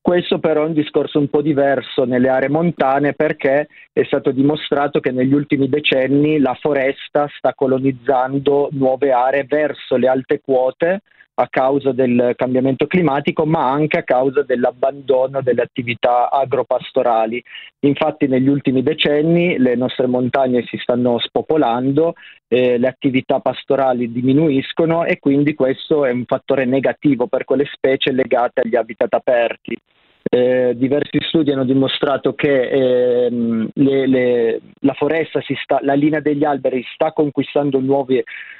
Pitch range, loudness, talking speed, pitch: 130-150 Hz, -17 LUFS, 140 wpm, 135 Hz